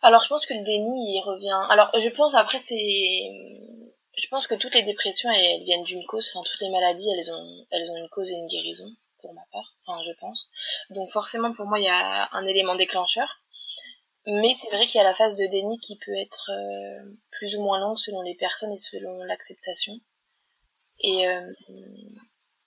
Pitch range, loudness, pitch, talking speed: 185-225 Hz, -22 LUFS, 205 Hz, 205 wpm